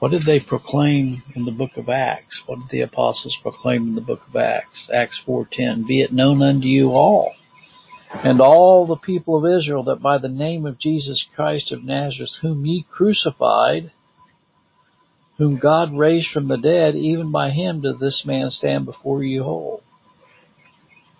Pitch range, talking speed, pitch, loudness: 135-160 Hz, 175 wpm, 145 Hz, -18 LUFS